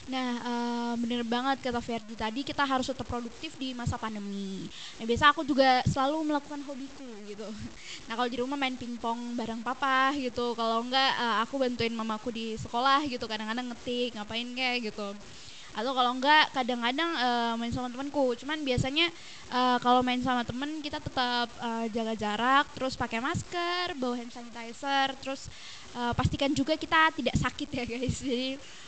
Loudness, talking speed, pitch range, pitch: -29 LUFS, 170 wpm, 235-275 Hz, 250 Hz